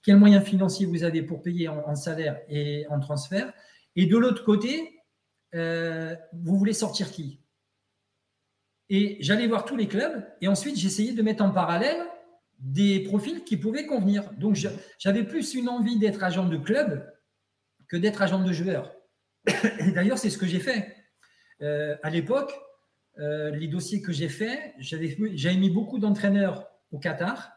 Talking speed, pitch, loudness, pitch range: 165 wpm, 195 Hz, -26 LUFS, 160-215 Hz